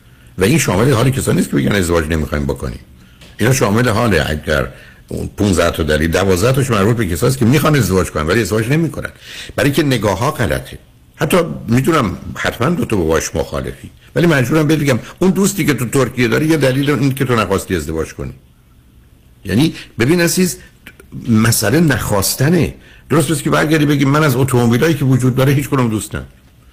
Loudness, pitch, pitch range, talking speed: -14 LUFS, 120 Hz, 95-145 Hz, 175 wpm